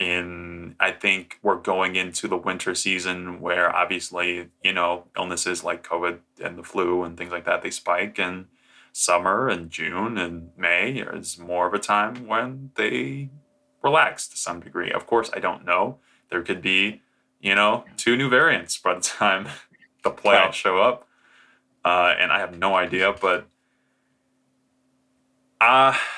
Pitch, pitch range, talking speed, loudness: 95 Hz, 90-130 Hz, 165 wpm, -22 LUFS